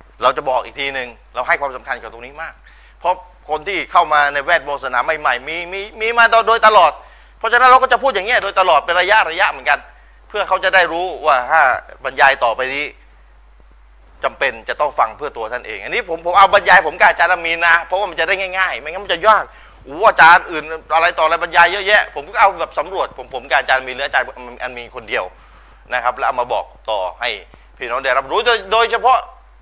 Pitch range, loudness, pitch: 150-205 Hz, -15 LUFS, 175 Hz